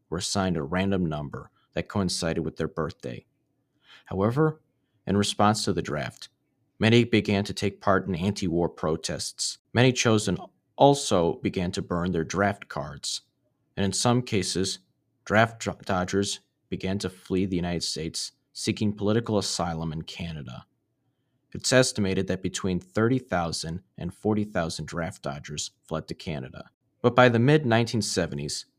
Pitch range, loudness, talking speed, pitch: 90-120 Hz, -26 LUFS, 140 wpm, 100 Hz